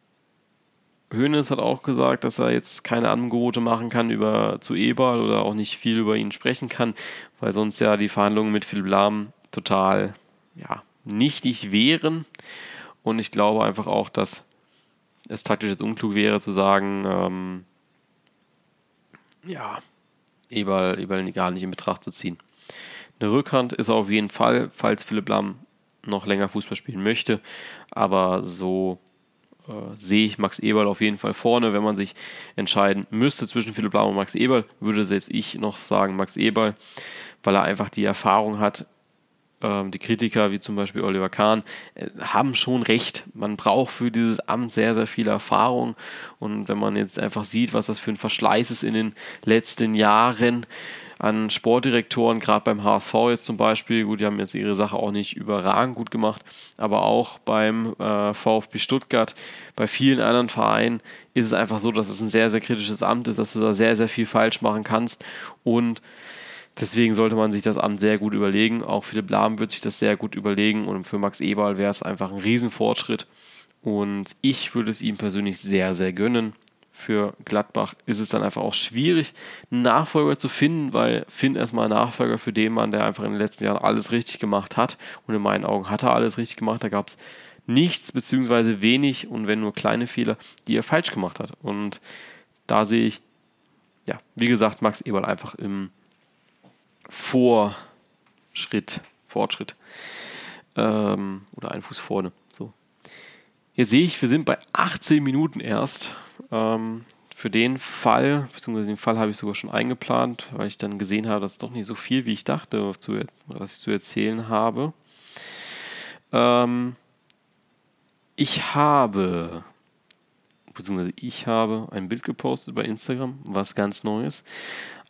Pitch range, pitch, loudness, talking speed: 100-115 Hz, 110 Hz, -23 LUFS, 170 wpm